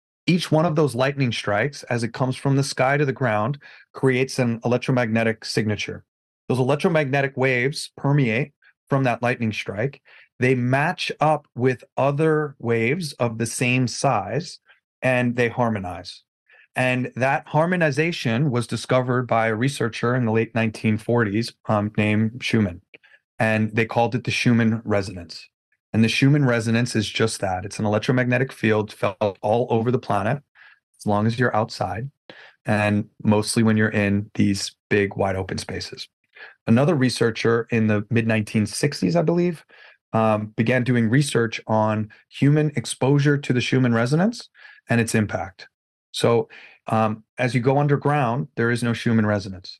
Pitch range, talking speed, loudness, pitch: 110-135 Hz, 150 wpm, -22 LUFS, 120 Hz